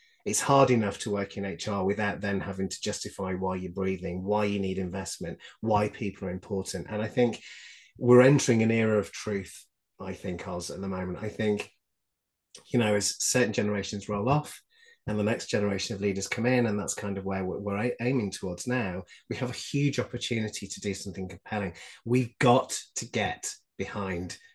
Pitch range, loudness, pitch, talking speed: 95-115 Hz, -29 LUFS, 105 Hz, 195 wpm